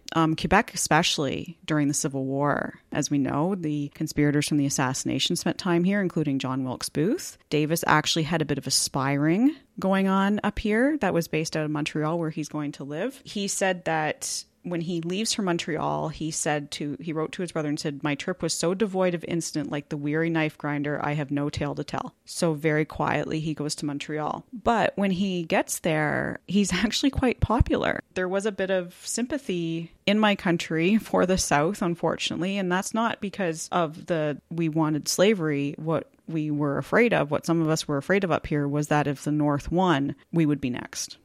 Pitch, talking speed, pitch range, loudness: 160 Hz, 205 wpm, 150-185 Hz, -26 LUFS